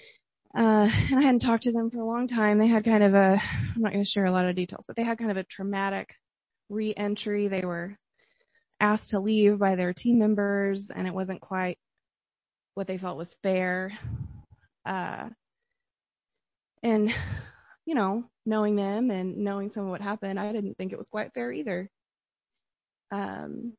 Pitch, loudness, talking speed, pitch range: 205 Hz, -27 LUFS, 175 wpm, 195-230 Hz